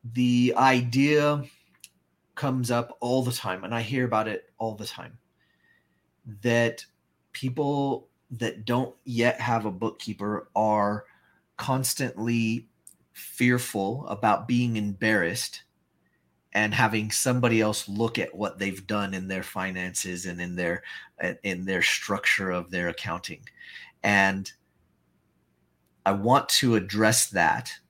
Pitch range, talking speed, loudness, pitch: 95-120 Hz, 120 wpm, -26 LUFS, 110 Hz